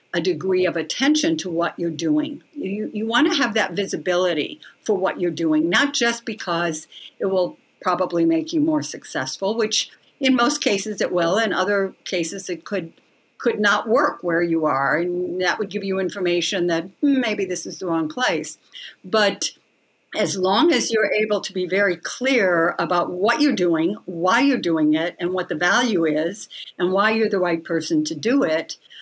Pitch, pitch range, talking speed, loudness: 185 Hz, 170-215 Hz, 190 wpm, -21 LUFS